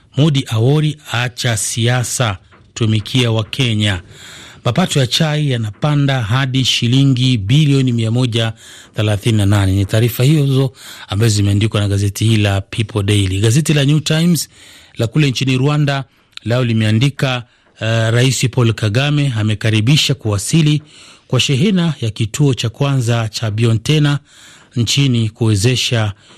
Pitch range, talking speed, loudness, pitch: 110-140 Hz, 120 wpm, -15 LUFS, 120 Hz